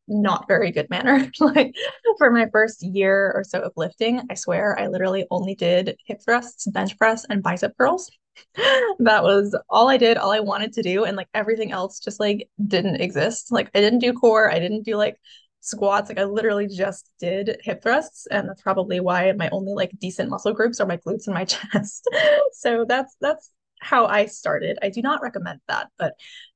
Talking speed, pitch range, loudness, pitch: 200 wpm, 195-235 Hz, -21 LUFS, 210 Hz